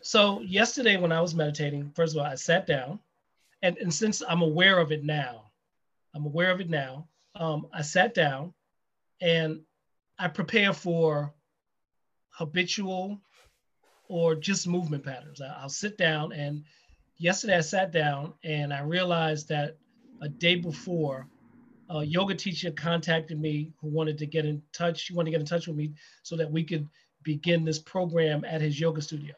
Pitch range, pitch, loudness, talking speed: 150-180 Hz, 165 Hz, -28 LUFS, 170 wpm